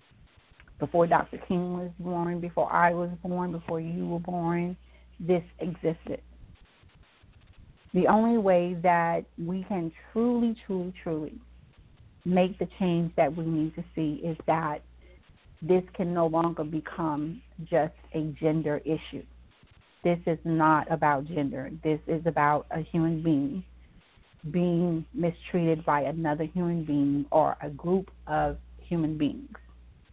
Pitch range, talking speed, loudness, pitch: 150-175 Hz, 130 wpm, -28 LUFS, 165 Hz